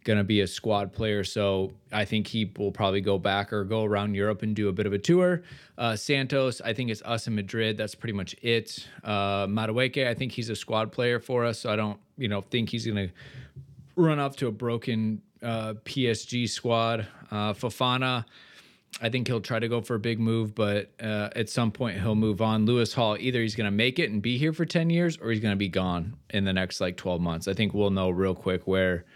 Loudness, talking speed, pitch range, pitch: -28 LUFS, 235 wpm, 105-120 Hz, 110 Hz